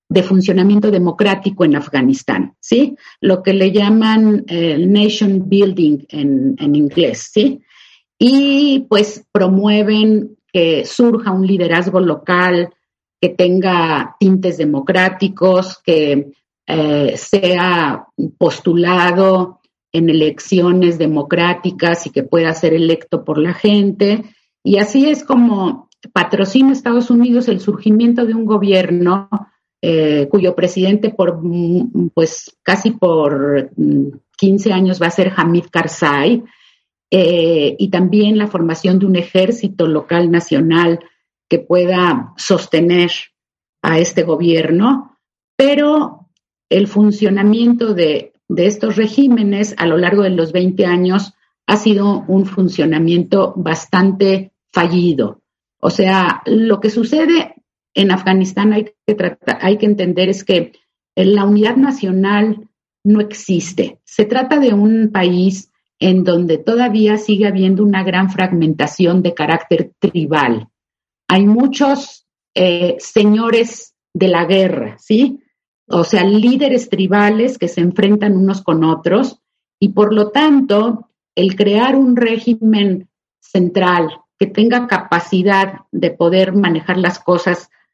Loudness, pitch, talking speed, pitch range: -13 LUFS, 190 Hz, 120 wpm, 175-215 Hz